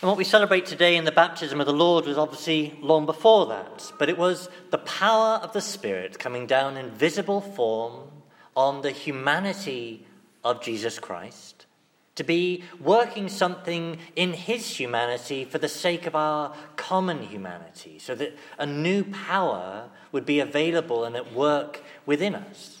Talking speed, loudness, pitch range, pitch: 165 wpm, -25 LUFS, 145-185 Hz, 160 Hz